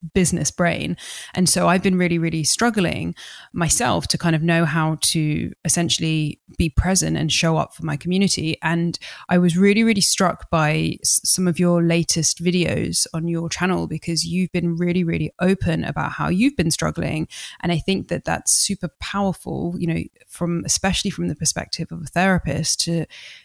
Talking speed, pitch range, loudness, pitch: 175 wpm, 160-180 Hz, -20 LUFS, 170 Hz